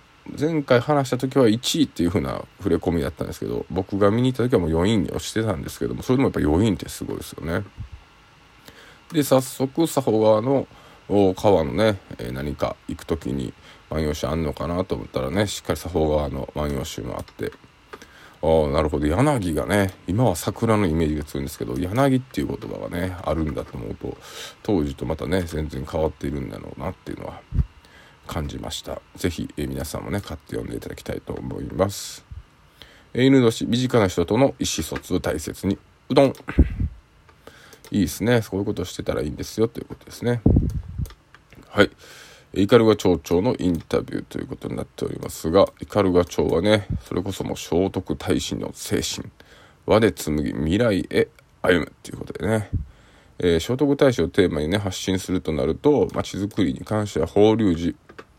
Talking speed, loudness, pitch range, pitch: 365 characters per minute, -23 LUFS, 80-110 Hz, 95 Hz